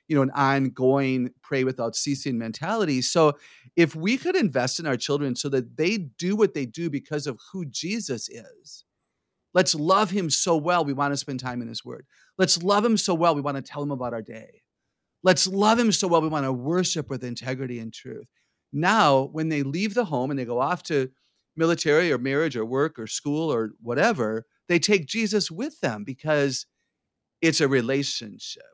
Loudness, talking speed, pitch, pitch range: -24 LUFS, 200 wpm, 145 Hz, 130-175 Hz